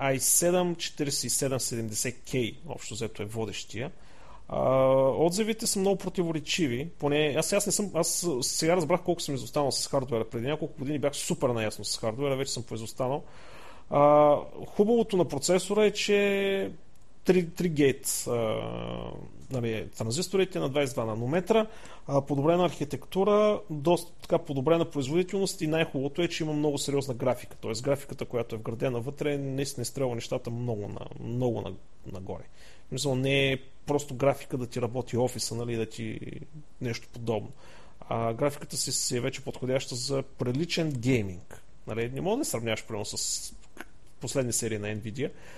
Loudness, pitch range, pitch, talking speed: -29 LUFS, 120-165 Hz, 140 Hz, 145 wpm